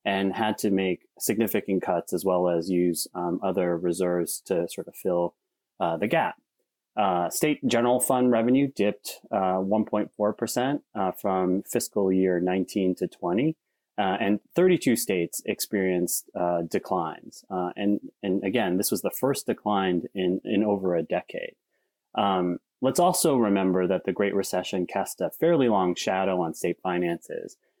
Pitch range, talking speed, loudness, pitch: 90-110 Hz, 155 wpm, -26 LUFS, 95 Hz